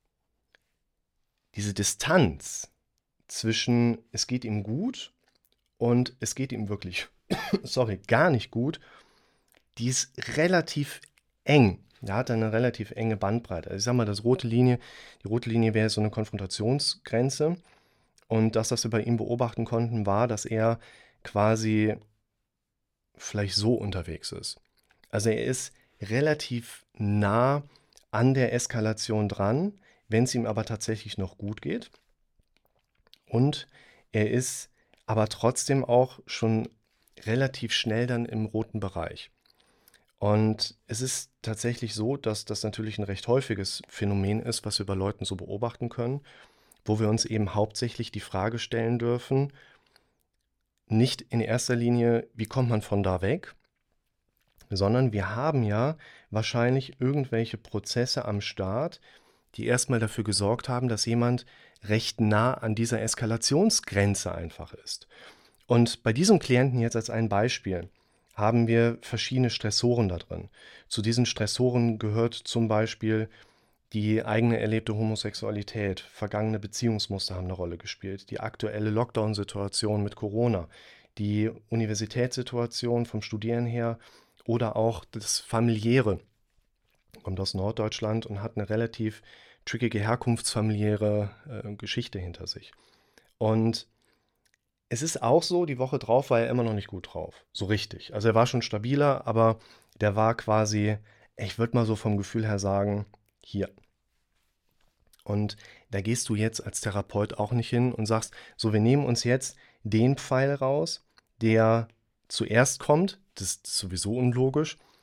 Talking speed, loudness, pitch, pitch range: 140 wpm, -28 LUFS, 115 Hz, 105-120 Hz